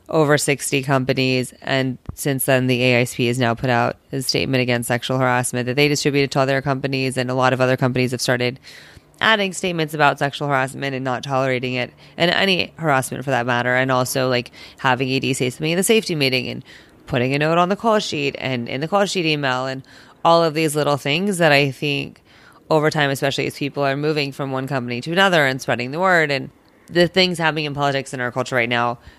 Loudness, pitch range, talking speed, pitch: -19 LUFS, 130-155 Hz, 220 wpm, 135 Hz